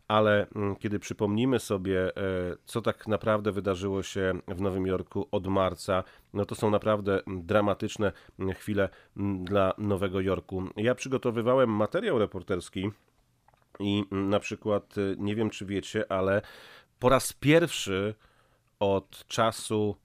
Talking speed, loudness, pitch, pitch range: 120 wpm, -29 LUFS, 100 Hz, 95-110 Hz